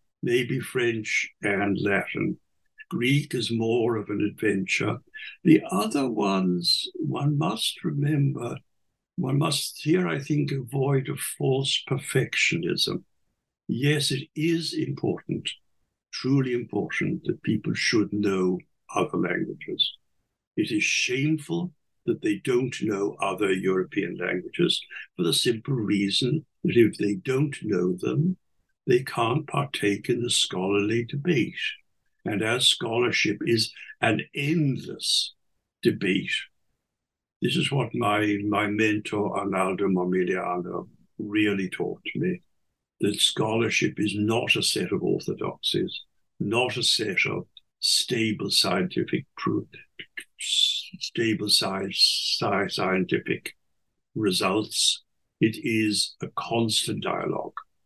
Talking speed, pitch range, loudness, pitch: 110 wpm, 105-145 Hz, -25 LUFS, 120 Hz